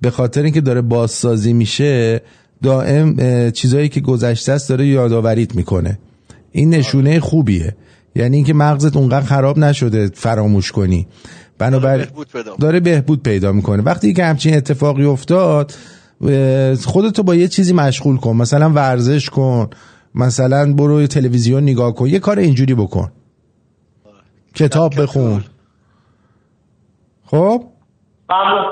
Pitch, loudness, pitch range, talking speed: 130 Hz, -14 LUFS, 115-150 Hz, 115 wpm